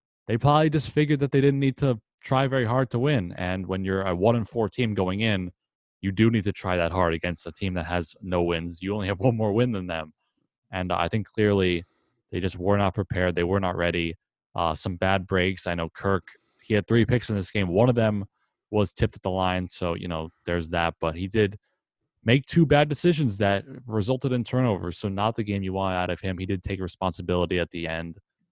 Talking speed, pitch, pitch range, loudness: 240 wpm, 95 Hz, 90-115 Hz, -25 LUFS